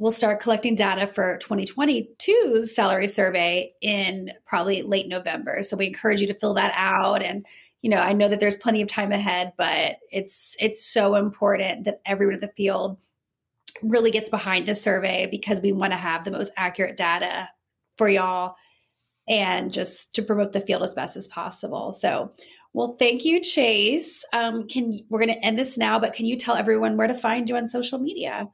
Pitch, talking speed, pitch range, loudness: 205 Hz, 195 wpm, 195-225 Hz, -23 LUFS